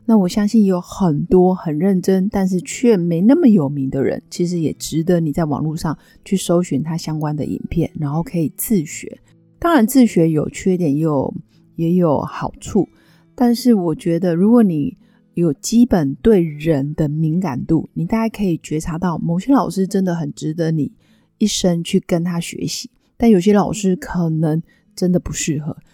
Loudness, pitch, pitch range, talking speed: -17 LUFS, 175 Hz, 160-200 Hz, 260 characters per minute